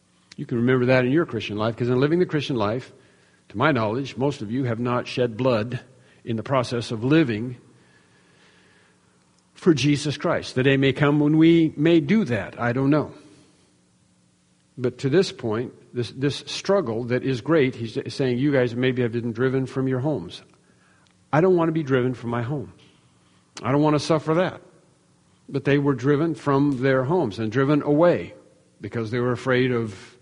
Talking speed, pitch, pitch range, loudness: 190 wpm, 130 Hz, 115-145 Hz, -22 LUFS